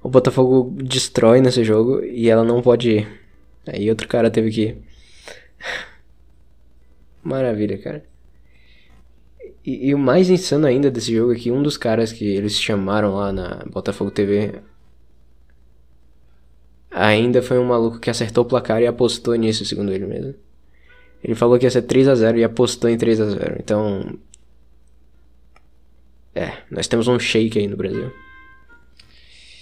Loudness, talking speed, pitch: -18 LUFS, 150 wpm, 105 Hz